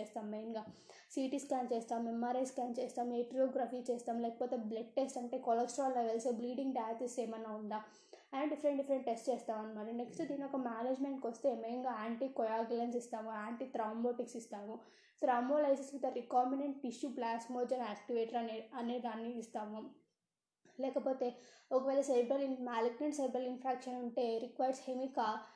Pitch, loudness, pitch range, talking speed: 245 Hz, -39 LUFS, 230-265 Hz, 130 wpm